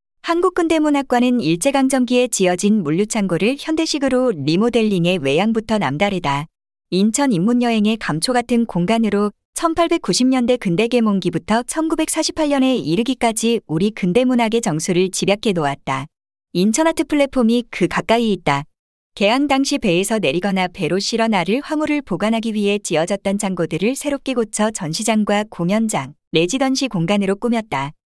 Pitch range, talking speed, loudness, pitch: 185-255 Hz, 335 characters per minute, -18 LUFS, 220 Hz